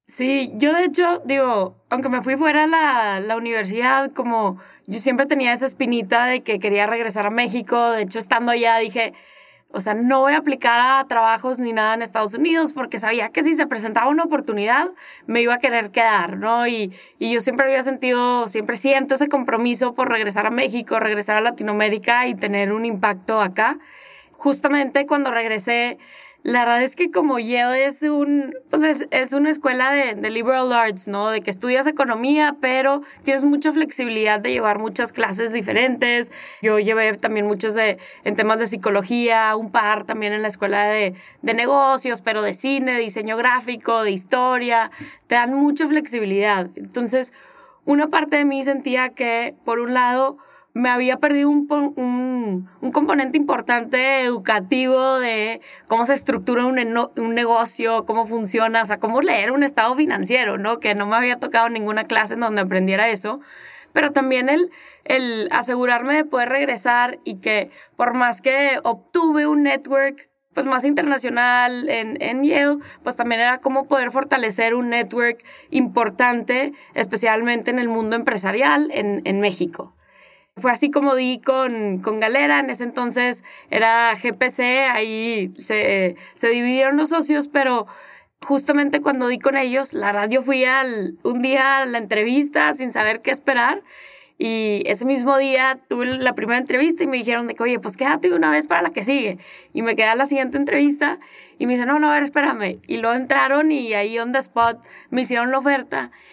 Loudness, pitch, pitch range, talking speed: -19 LUFS, 245 Hz, 225-275 Hz, 175 wpm